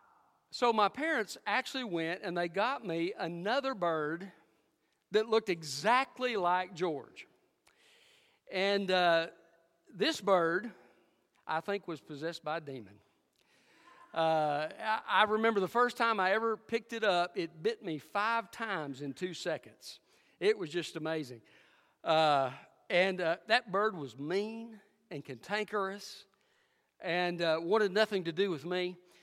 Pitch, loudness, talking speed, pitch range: 185 Hz, -33 LUFS, 140 wpm, 165-225 Hz